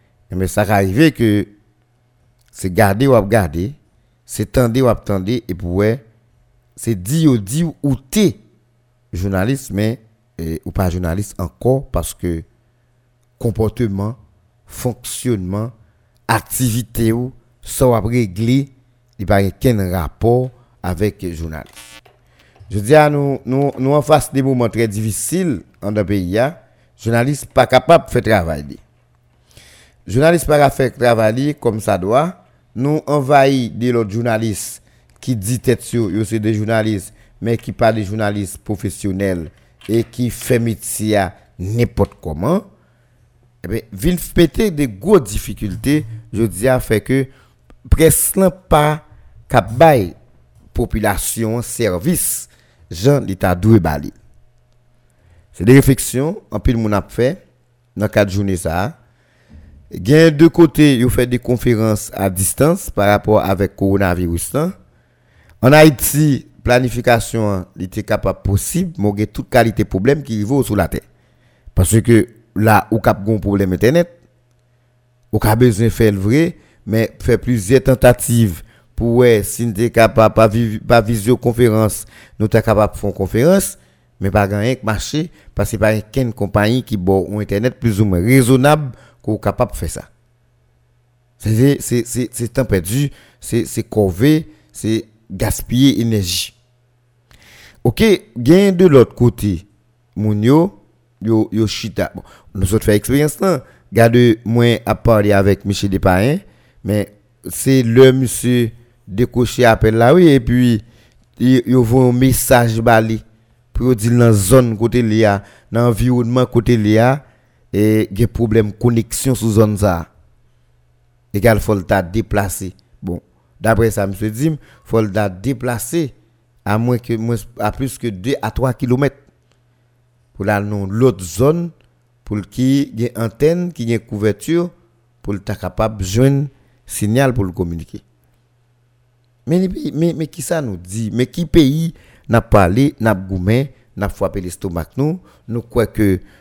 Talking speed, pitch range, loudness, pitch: 140 wpm, 105-125 Hz, -16 LUFS, 115 Hz